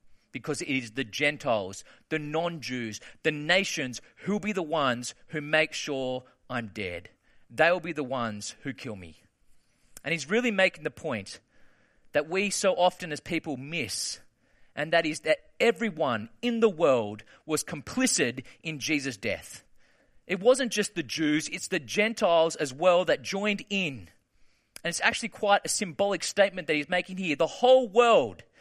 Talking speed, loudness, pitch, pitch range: 170 wpm, -27 LUFS, 160 Hz, 135-195 Hz